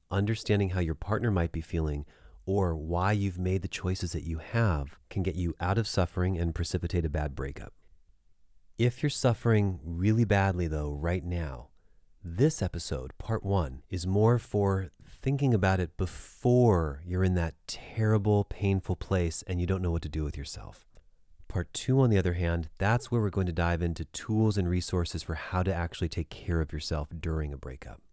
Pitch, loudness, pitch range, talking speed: 90 Hz, -30 LUFS, 80-105 Hz, 190 wpm